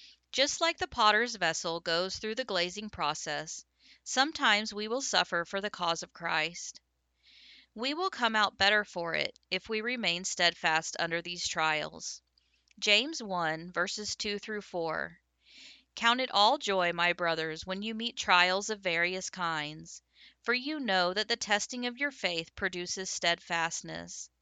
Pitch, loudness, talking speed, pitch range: 185 Hz, -30 LUFS, 155 wpm, 170-220 Hz